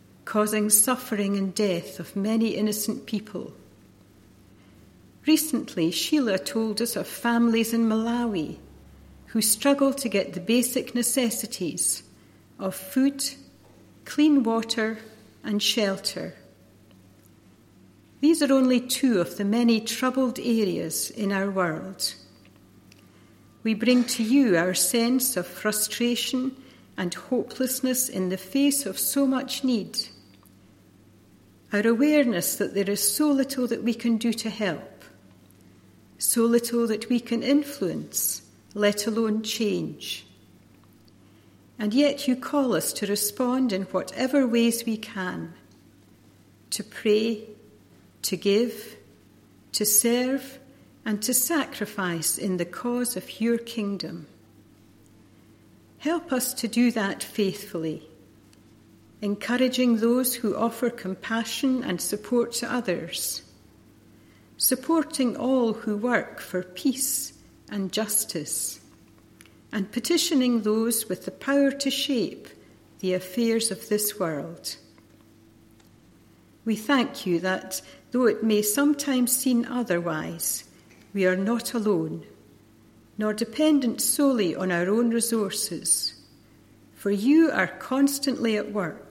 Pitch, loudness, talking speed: 210 Hz, -25 LUFS, 115 wpm